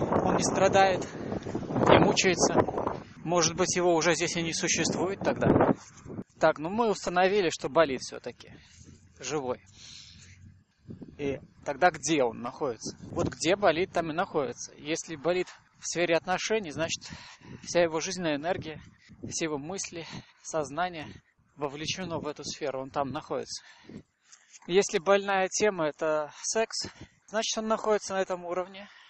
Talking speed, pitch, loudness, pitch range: 130 wpm, 165 Hz, -28 LUFS, 150-185 Hz